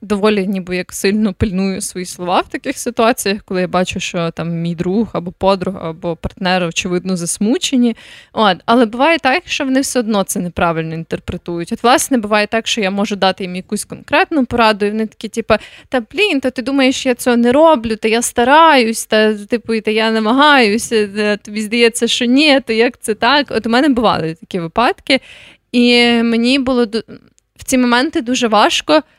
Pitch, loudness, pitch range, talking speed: 225 Hz, -14 LUFS, 195-250 Hz, 190 wpm